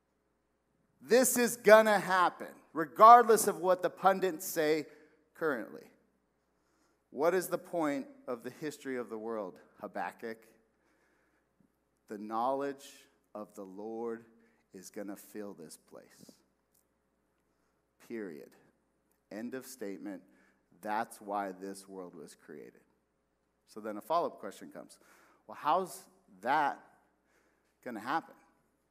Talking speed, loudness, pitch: 120 wpm, -30 LUFS, 120 Hz